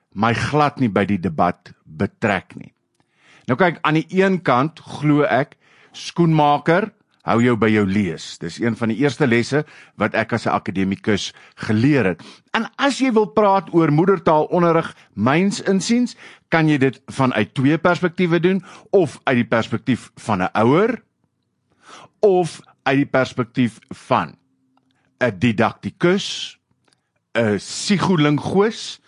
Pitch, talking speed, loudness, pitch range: 145 Hz, 140 wpm, -19 LUFS, 120-180 Hz